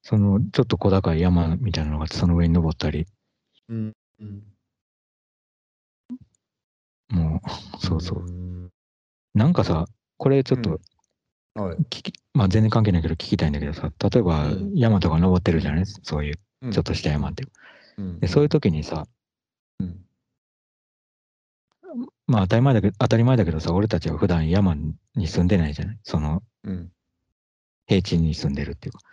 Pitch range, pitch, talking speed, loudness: 80-110 Hz, 90 Hz, 285 characters per minute, -23 LUFS